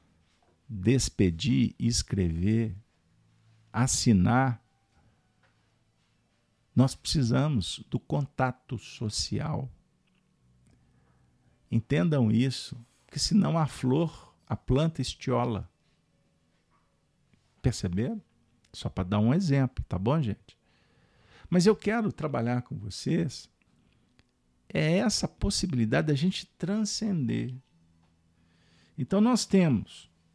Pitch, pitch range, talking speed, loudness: 120 Hz, 100-145 Hz, 85 wpm, -28 LUFS